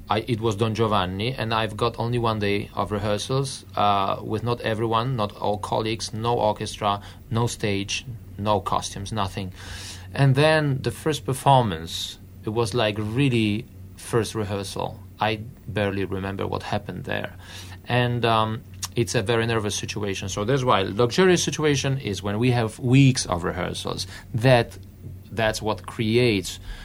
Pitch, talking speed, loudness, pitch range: 110 Hz, 160 wpm, -24 LUFS, 100-120 Hz